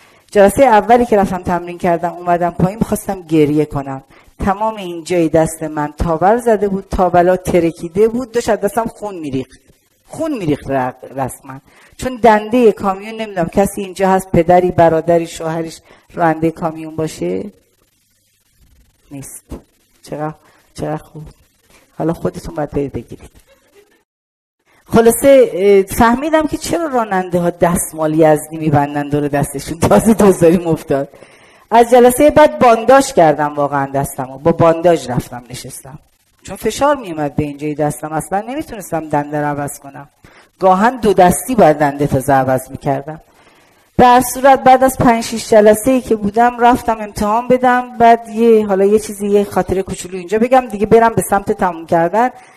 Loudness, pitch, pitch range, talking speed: -14 LUFS, 180 Hz, 150-225 Hz, 145 wpm